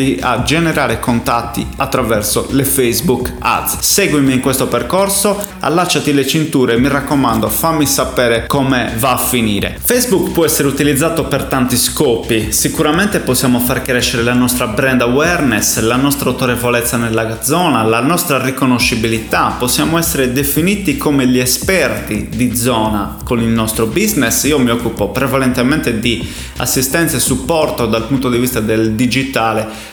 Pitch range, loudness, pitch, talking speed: 115-145 Hz, -13 LUFS, 130 Hz, 140 wpm